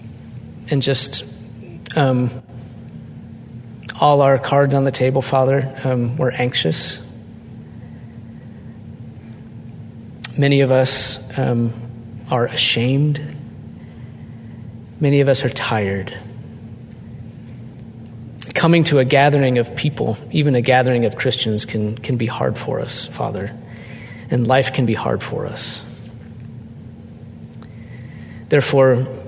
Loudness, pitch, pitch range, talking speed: -18 LUFS, 120 Hz, 115-130 Hz, 100 wpm